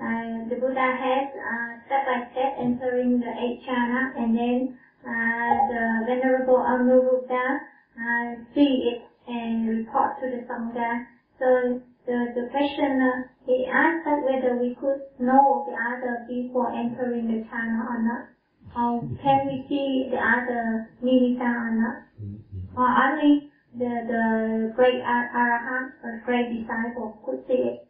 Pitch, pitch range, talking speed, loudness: 245 Hz, 235-260 Hz, 150 wpm, -24 LUFS